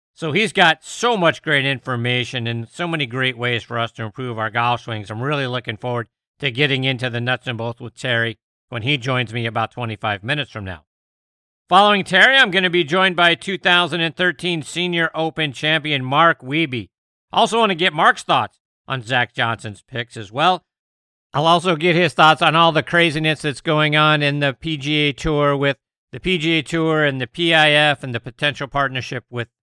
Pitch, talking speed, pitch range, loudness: 140 Hz, 195 wpm, 120-165 Hz, -18 LUFS